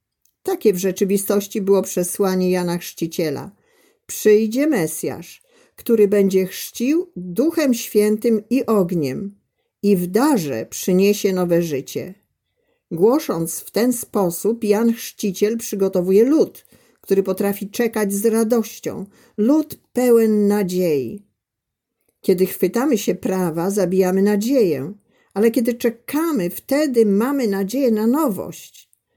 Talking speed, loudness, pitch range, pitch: 105 wpm, -19 LUFS, 190-235 Hz, 210 Hz